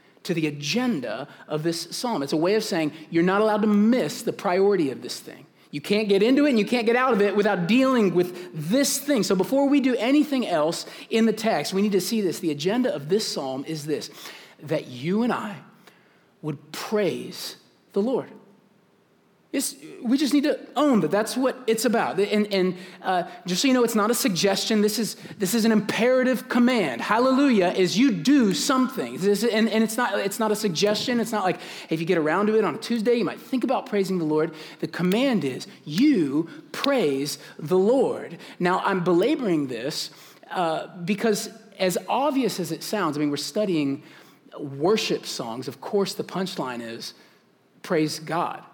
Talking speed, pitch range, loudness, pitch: 200 wpm, 180-245 Hz, -23 LUFS, 210 Hz